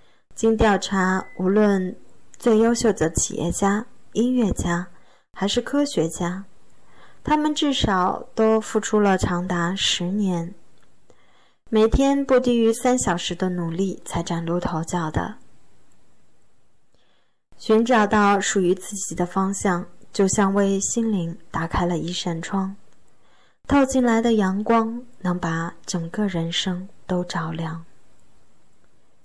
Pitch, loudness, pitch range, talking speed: 195 Hz, -22 LUFS, 175-220 Hz, 175 characters per minute